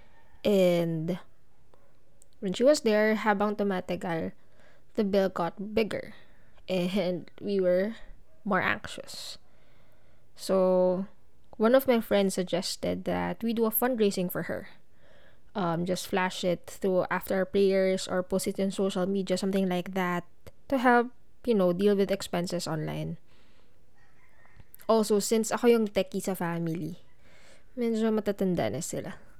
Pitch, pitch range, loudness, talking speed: 190 Hz, 180-215 Hz, -28 LUFS, 130 wpm